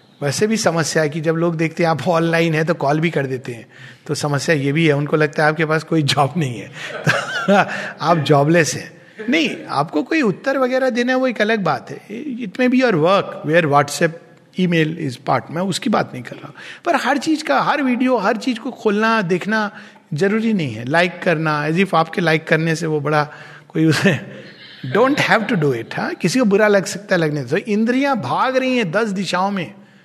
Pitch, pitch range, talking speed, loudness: 170 Hz, 155-220 Hz, 230 wpm, -18 LUFS